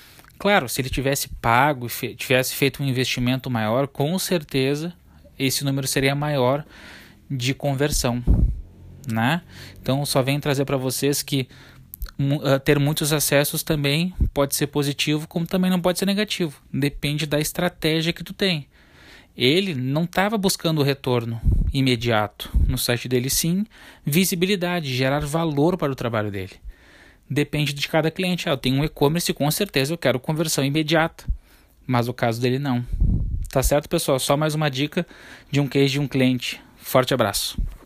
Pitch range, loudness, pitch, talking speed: 130-160 Hz, -22 LUFS, 140 Hz, 155 wpm